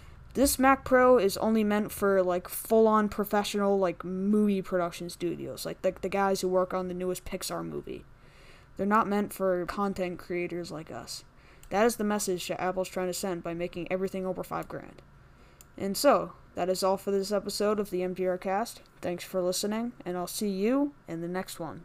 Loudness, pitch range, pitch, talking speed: -29 LUFS, 180-210 Hz, 190 Hz, 200 wpm